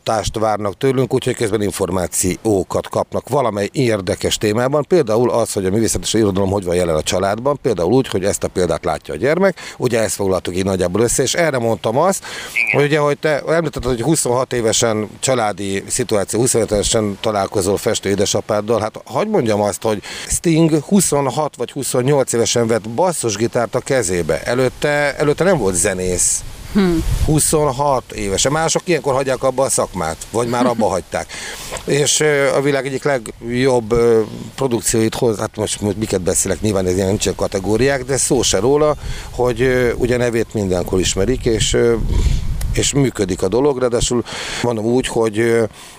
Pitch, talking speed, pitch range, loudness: 120 Hz, 155 wpm, 105-135 Hz, -17 LUFS